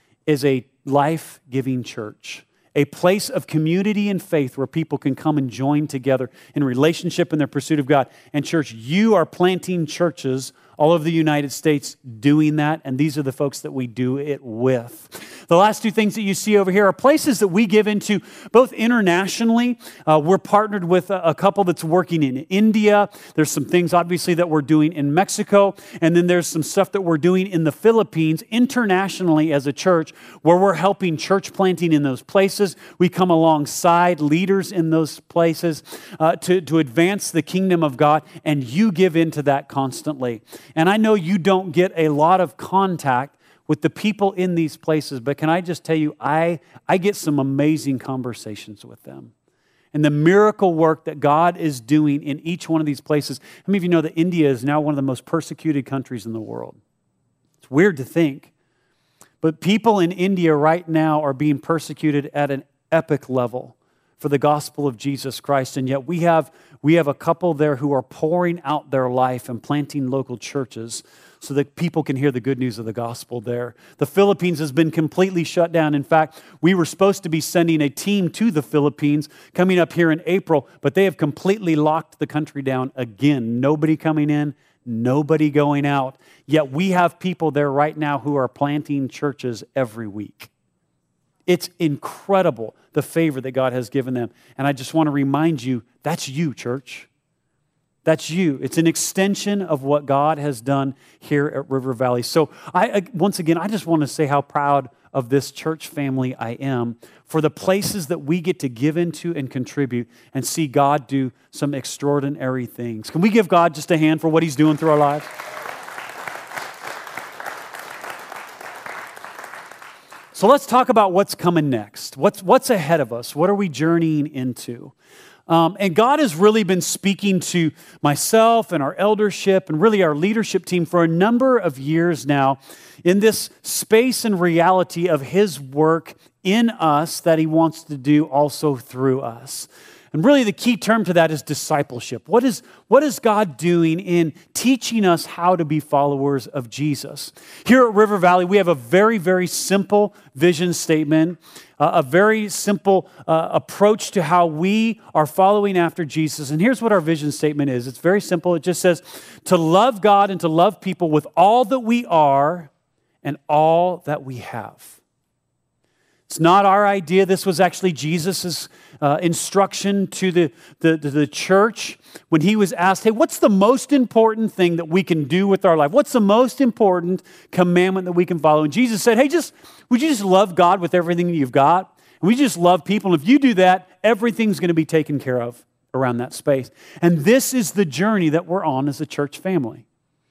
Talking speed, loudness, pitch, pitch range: 190 wpm, -19 LUFS, 160 Hz, 145-185 Hz